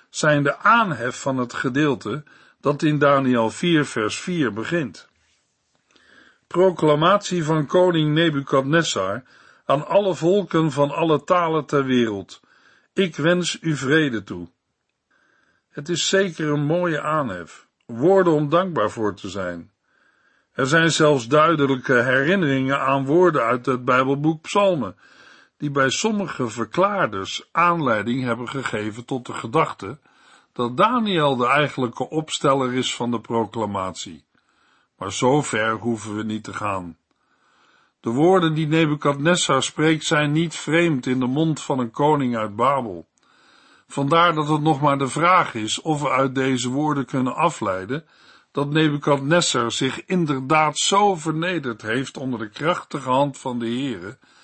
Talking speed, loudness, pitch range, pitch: 140 wpm, -20 LUFS, 125-160 Hz, 145 Hz